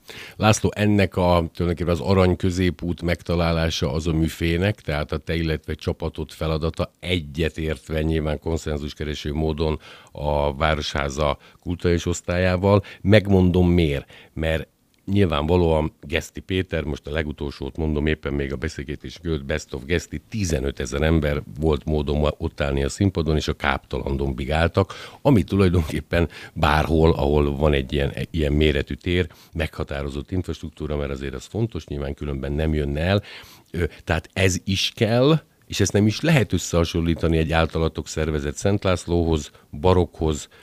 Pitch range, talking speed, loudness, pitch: 75-90 Hz, 135 wpm, -23 LUFS, 80 Hz